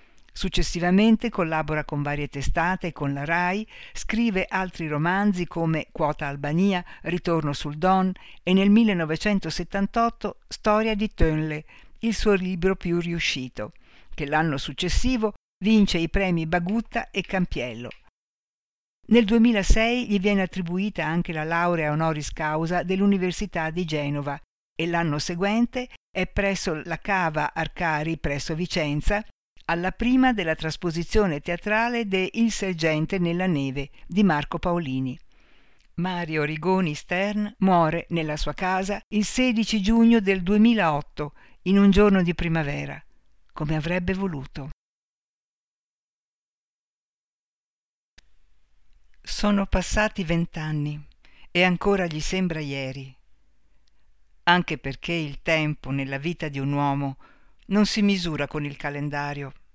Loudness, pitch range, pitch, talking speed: -24 LUFS, 155-195 Hz, 175 Hz, 115 wpm